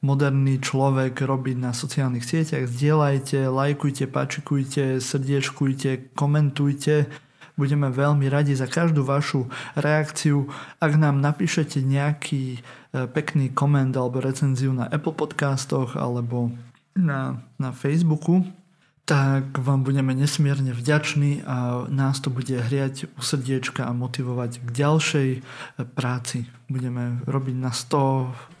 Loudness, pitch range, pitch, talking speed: -23 LUFS, 130-145 Hz, 135 Hz, 115 wpm